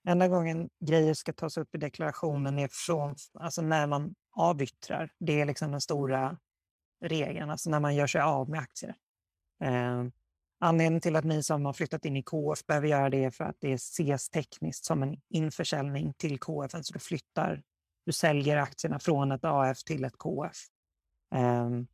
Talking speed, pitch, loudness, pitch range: 185 wpm, 150 Hz, -31 LUFS, 135-165 Hz